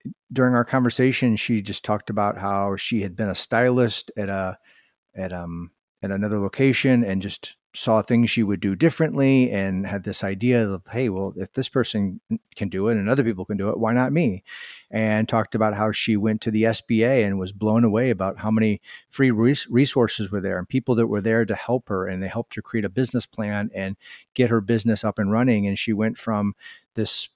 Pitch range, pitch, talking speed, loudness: 100-120 Hz, 110 Hz, 215 wpm, -22 LUFS